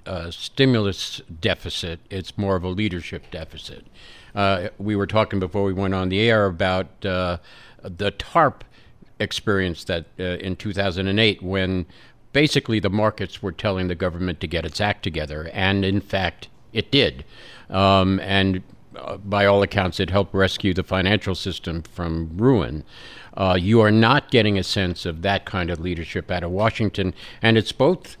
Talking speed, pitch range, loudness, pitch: 165 wpm, 90-105 Hz, -22 LUFS, 95 Hz